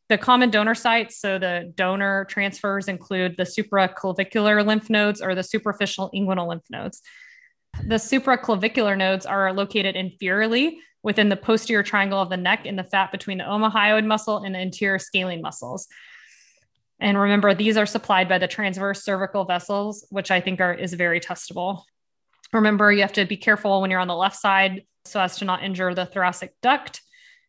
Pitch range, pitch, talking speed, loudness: 185-215 Hz, 195 Hz, 175 wpm, -22 LUFS